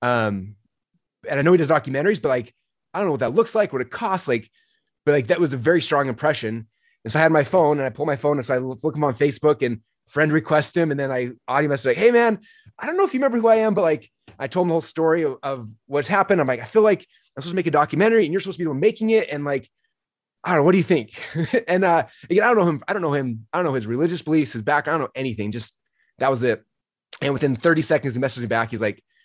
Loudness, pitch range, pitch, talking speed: -21 LUFS, 130-180 Hz, 150 Hz, 300 wpm